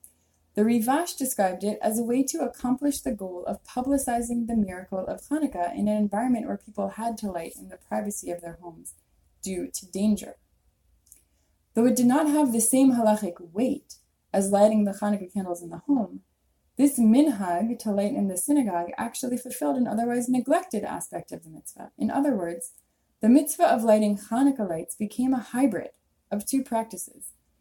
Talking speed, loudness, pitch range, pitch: 180 wpm, -26 LUFS, 180-250 Hz, 215 Hz